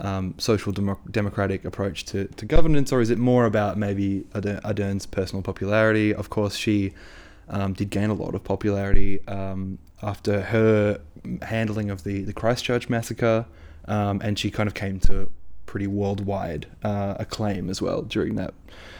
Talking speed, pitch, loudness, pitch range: 160 wpm, 100 Hz, -25 LUFS, 95-105 Hz